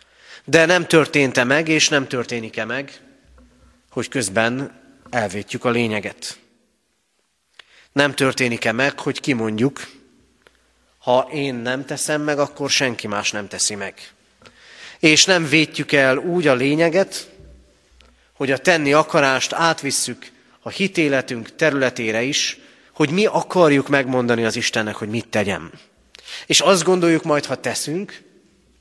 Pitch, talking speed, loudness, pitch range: 135 Hz, 125 wpm, -18 LUFS, 115-150 Hz